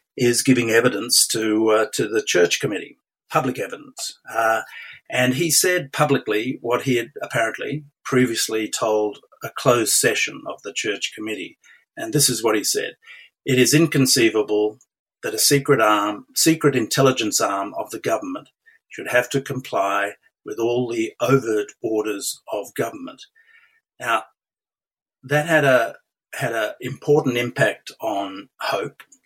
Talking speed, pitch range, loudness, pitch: 140 wpm, 110-155 Hz, -20 LUFS, 130 Hz